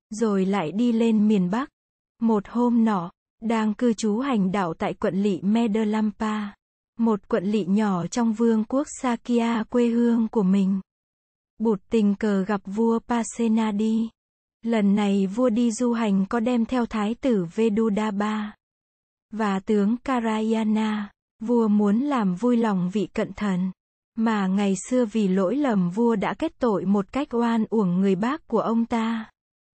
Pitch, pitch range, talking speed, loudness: 220 Hz, 205-235 Hz, 155 wpm, -23 LUFS